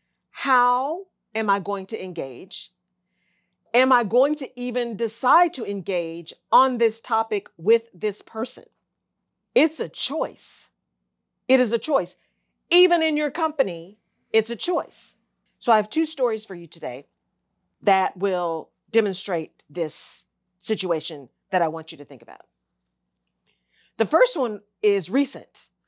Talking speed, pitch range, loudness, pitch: 135 wpm, 170-250 Hz, -23 LUFS, 215 Hz